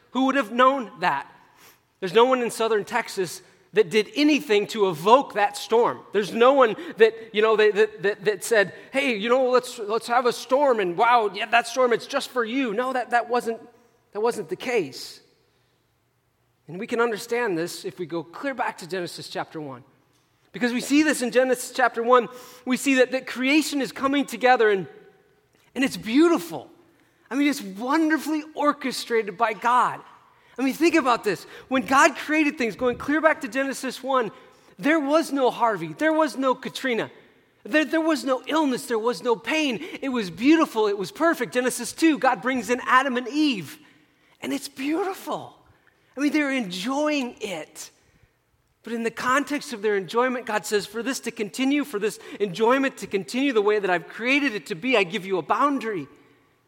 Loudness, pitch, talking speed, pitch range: -23 LUFS, 245 Hz, 190 wpm, 215-270 Hz